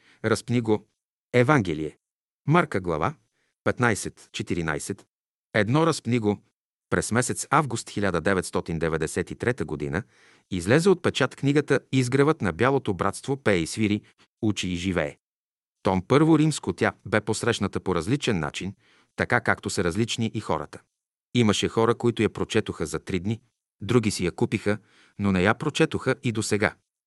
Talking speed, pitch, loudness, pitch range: 140 wpm, 110 Hz, -25 LUFS, 95-120 Hz